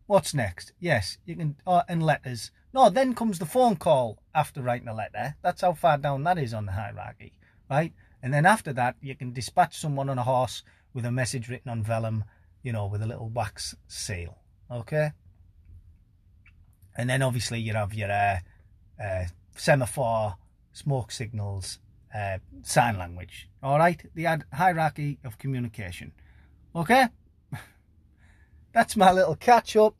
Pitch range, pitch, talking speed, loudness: 95-150 Hz, 115 Hz, 160 wpm, -26 LUFS